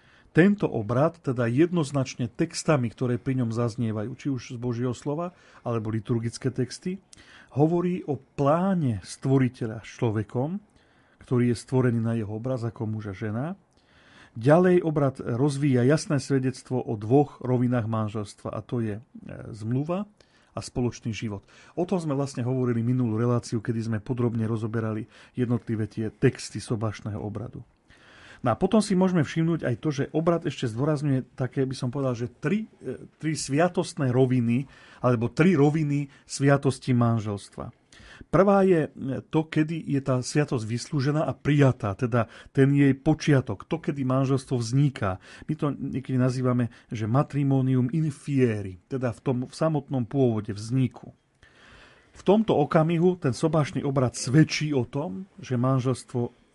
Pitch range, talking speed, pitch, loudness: 120-150 Hz, 140 wpm, 130 Hz, -26 LUFS